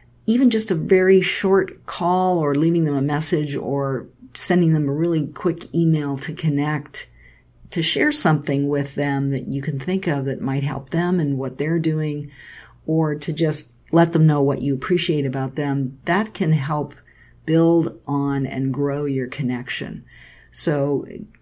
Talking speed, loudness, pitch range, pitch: 165 wpm, -20 LUFS, 140-165 Hz, 150 Hz